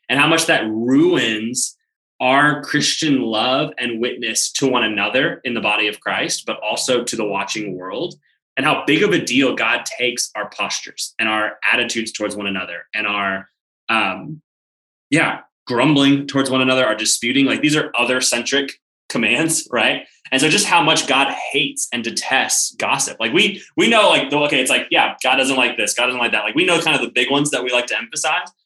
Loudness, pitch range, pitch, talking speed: -17 LUFS, 110-140 Hz, 125 Hz, 205 wpm